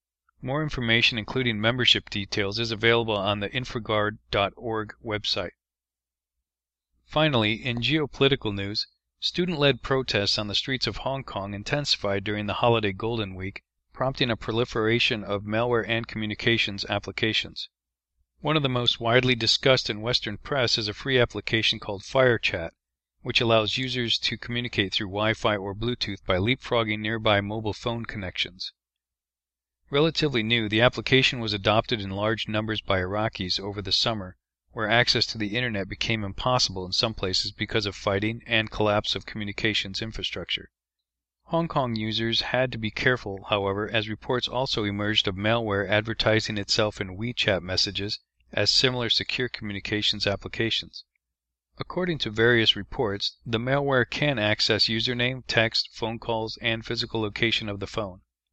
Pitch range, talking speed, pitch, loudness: 100-120 Hz, 145 wpm, 110 Hz, -25 LUFS